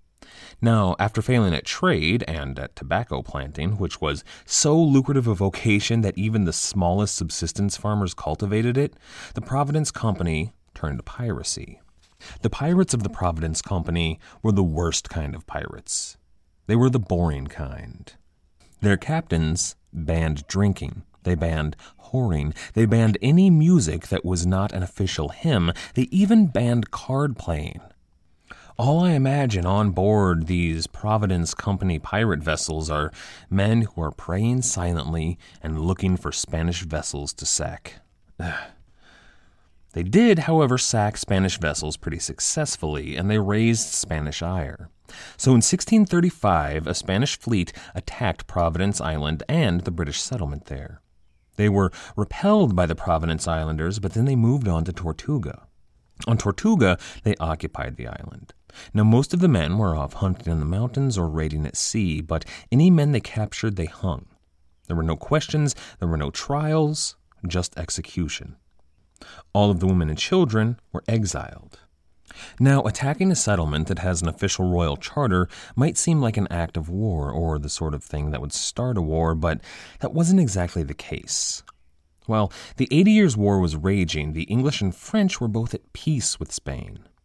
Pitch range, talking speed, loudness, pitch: 80-115 Hz, 155 wpm, -23 LUFS, 95 Hz